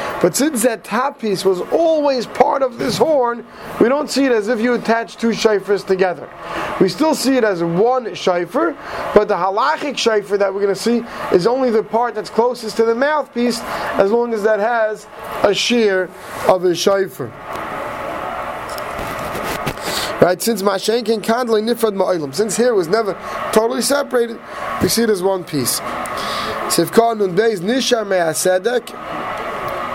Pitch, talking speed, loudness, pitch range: 220 Hz, 160 wpm, -17 LUFS, 195-240 Hz